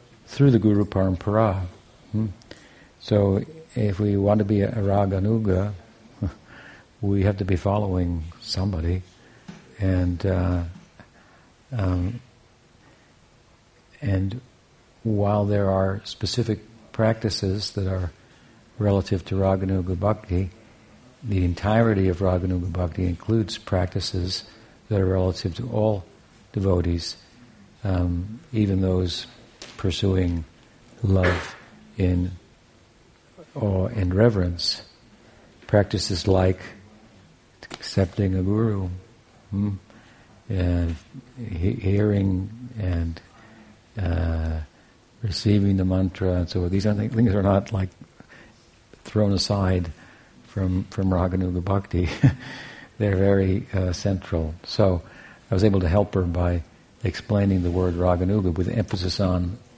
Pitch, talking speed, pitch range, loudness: 100 Hz, 100 wpm, 90-110 Hz, -24 LUFS